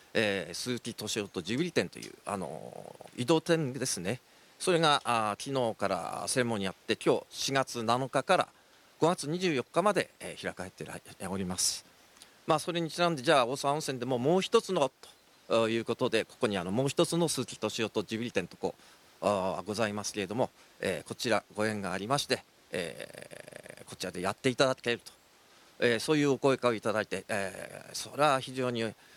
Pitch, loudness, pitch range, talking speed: 125 Hz, -31 LUFS, 110-145 Hz, 360 characters per minute